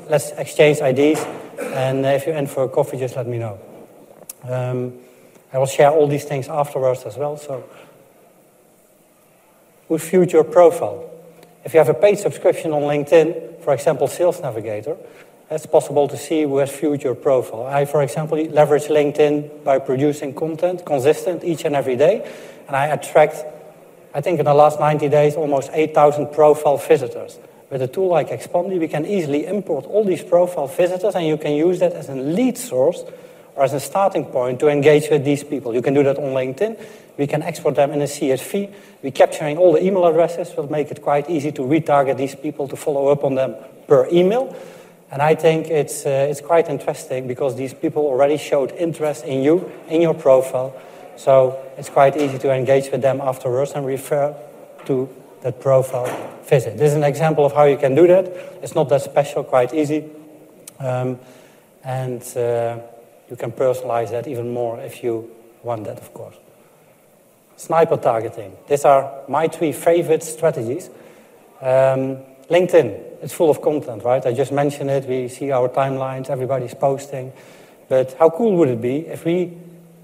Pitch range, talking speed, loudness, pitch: 135-160 Hz, 180 wpm, -18 LUFS, 145 Hz